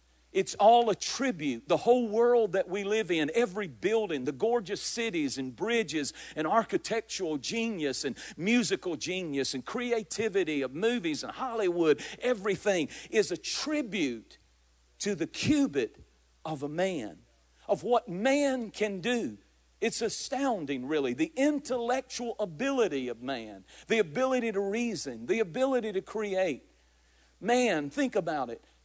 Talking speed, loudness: 135 wpm, -30 LUFS